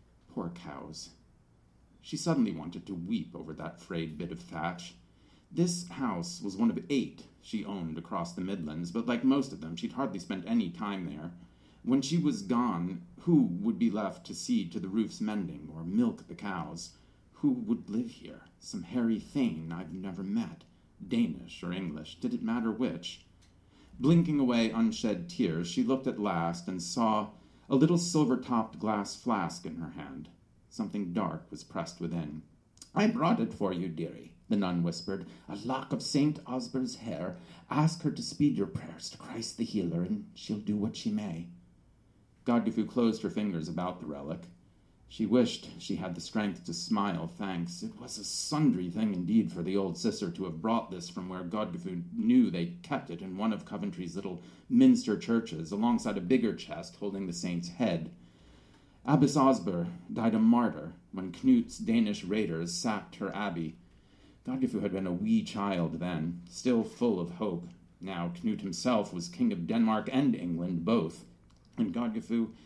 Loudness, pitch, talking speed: -32 LUFS, 115 Hz, 175 wpm